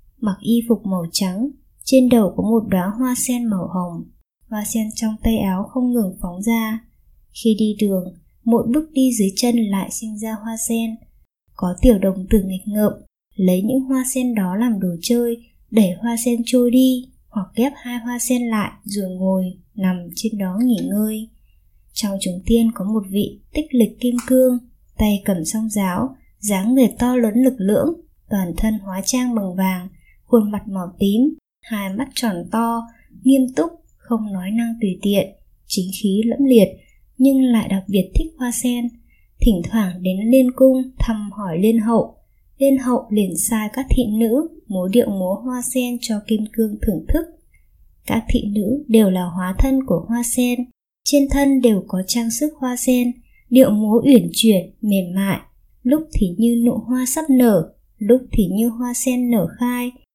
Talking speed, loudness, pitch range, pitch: 185 wpm, -19 LUFS, 200-245 Hz, 225 Hz